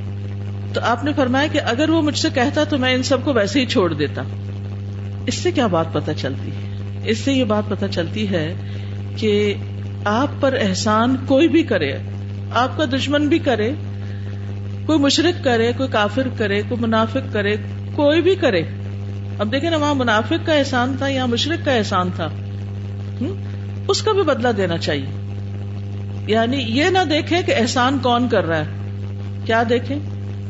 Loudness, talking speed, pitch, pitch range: -19 LUFS, 175 wpm, 100 Hz, 100-130 Hz